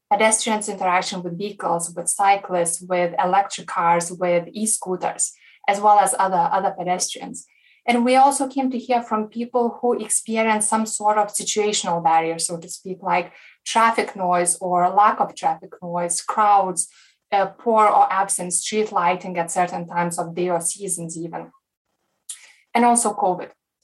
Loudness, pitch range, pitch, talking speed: -20 LUFS, 175-220 Hz, 195 Hz, 155 wpm